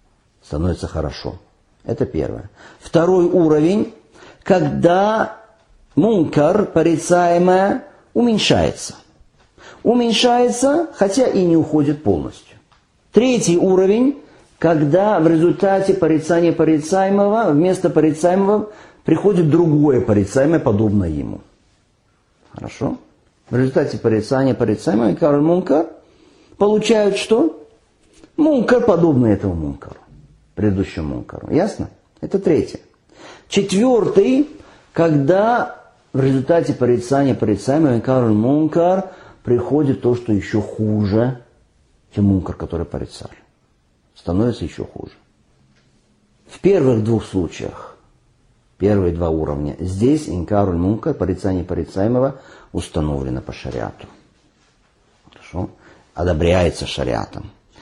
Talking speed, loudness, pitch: 90 wpm, -17 LUFS, 145 Hz